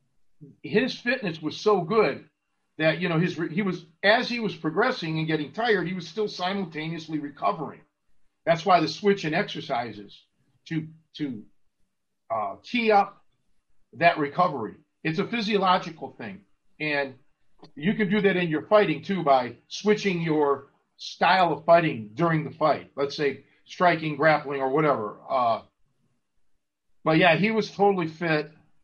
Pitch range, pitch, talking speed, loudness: 150-200 Hz, 165 Hz, 150 wpm, -25 LUFS